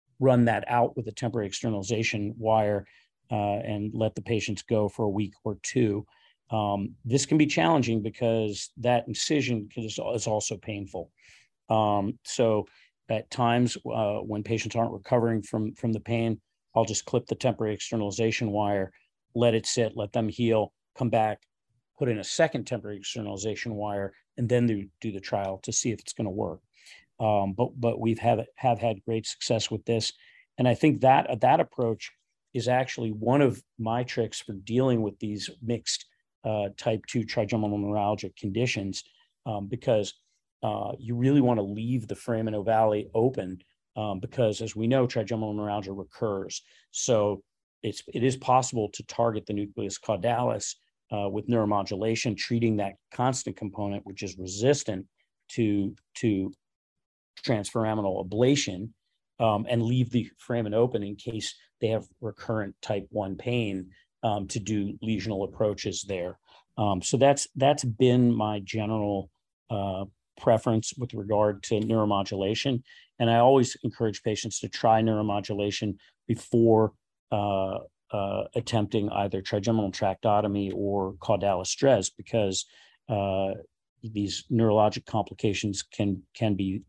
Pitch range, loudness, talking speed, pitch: 100-120 Hz, -28 LUFS, 150 wpm, 110 Hz